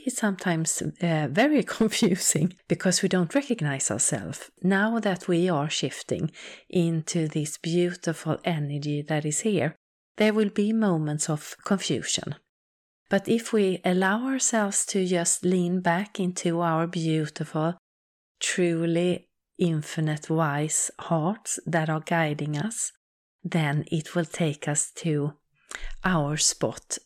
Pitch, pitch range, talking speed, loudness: 170 Hz, 155-190 Hz, 125 wpm, -26 LUFS